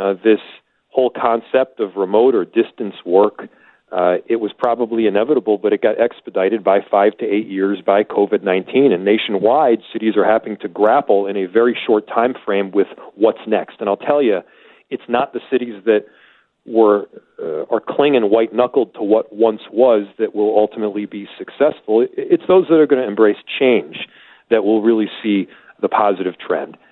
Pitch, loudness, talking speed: 115 Hz, -16 LUFS, 175 wpm